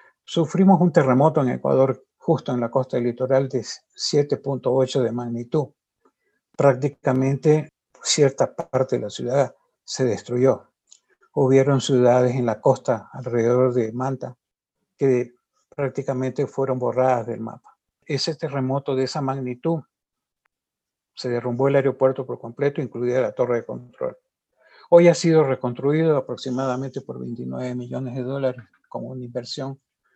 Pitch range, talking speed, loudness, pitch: 125-140 Hz, 130 wpm, -22 LUFS, 130 Hz